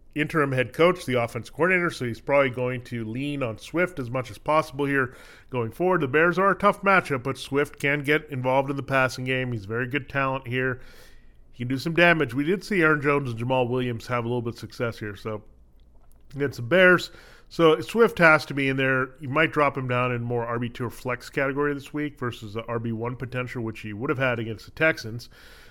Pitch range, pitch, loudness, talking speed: 120-150 Hz, 130 Hz, -24 LUFS, 225 wpm